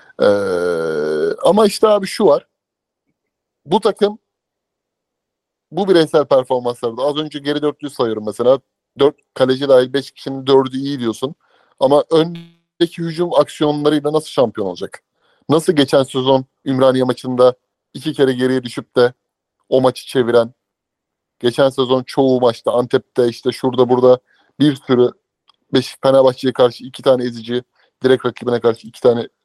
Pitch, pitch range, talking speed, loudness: 135 Hz, 125-155 Hz, 135 wpm, -16 LUFS